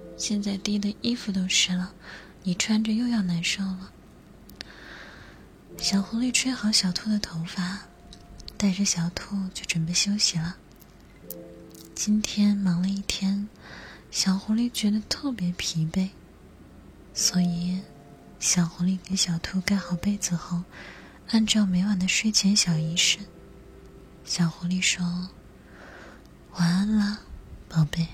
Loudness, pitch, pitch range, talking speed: -25 LUFS, 190 Hz, 175-205 Hz, 180 characters per minute